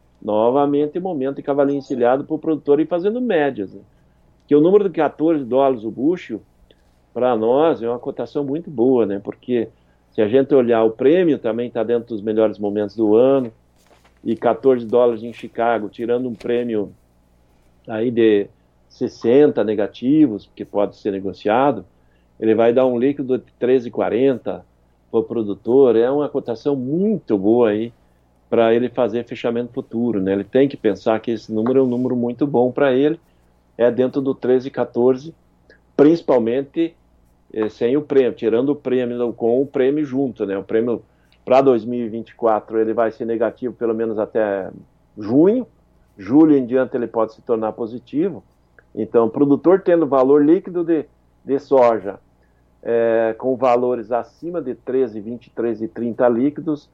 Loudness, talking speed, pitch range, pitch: -18 LUFS, 160 wpm, 105-135 Hz, 120 Hz